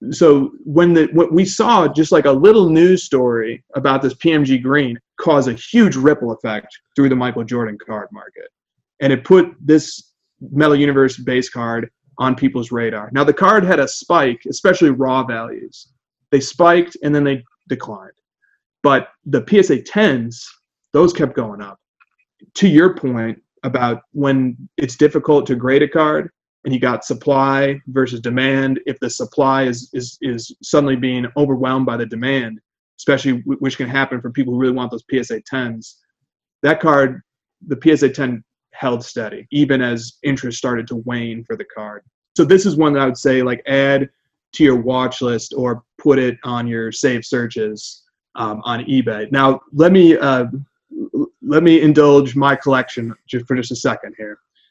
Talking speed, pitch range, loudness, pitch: 175 wpm, 125-145 Hz, -16 LUFS, 135 Hz